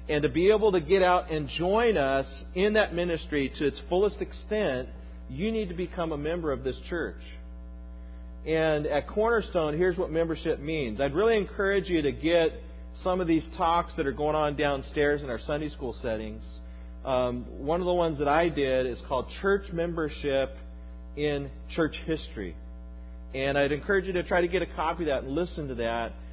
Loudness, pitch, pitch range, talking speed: -28 LUFS, 150 Hz, 125-175 Hz, 190 wpm